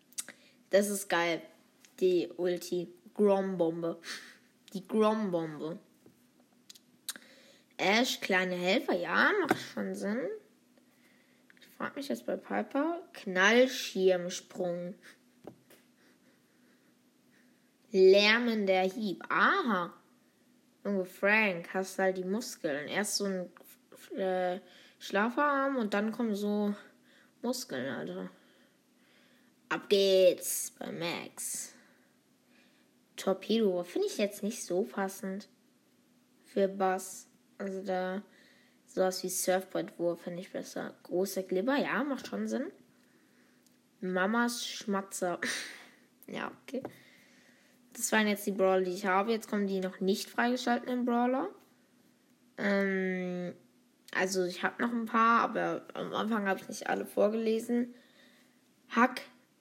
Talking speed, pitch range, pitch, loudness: 110 wpm, 185-255 Hz, 205 Hz, -31 LUFS